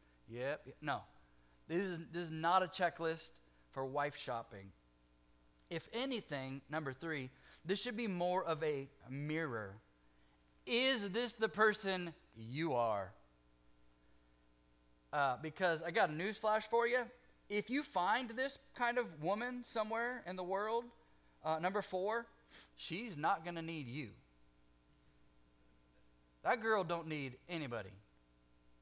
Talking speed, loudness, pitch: 130 wpm, -39 LUFS, 155 Hz